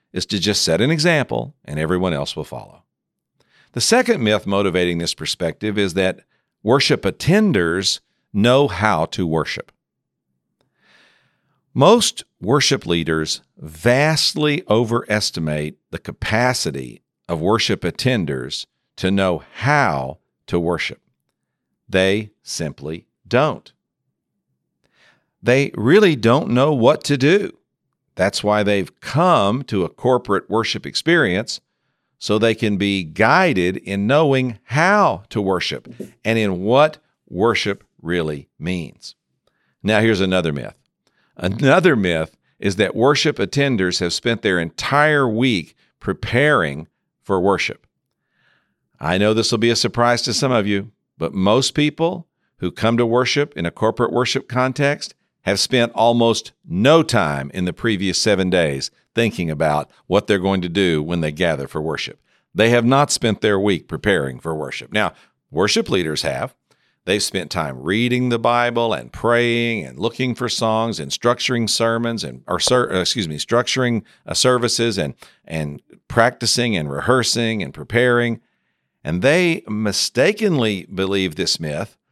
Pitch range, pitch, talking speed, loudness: 90-120 Hz, 110 Hz, 135 wpm, -18 LUFS